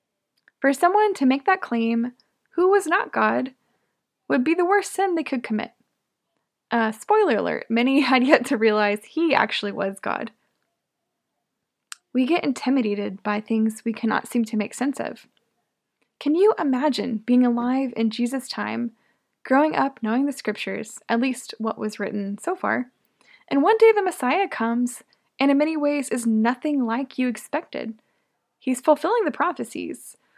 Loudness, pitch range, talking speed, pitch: -22 LUFS, 225-300 Hz, 160 wpm, 255 Hz